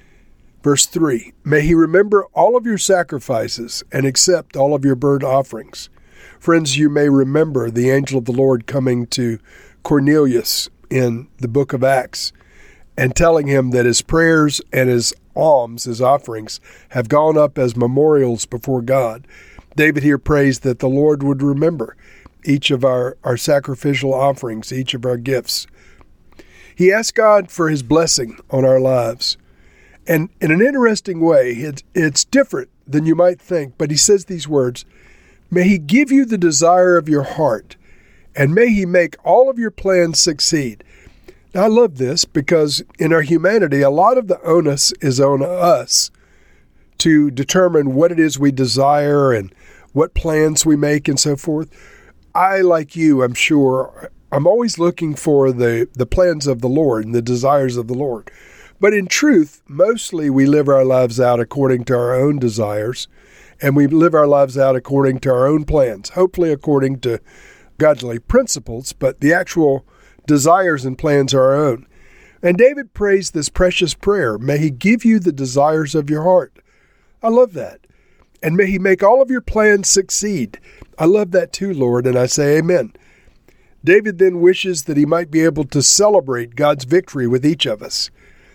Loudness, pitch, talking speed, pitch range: -15 LUFS, 145 Hz, 175 wpm, 130-175 Hz